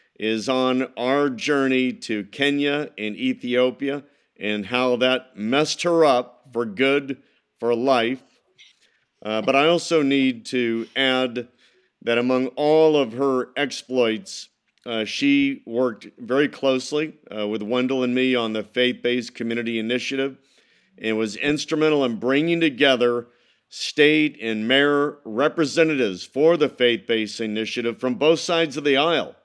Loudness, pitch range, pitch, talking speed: -21 LUFS, 120-145 Hz, 130 Hz, 140 wpm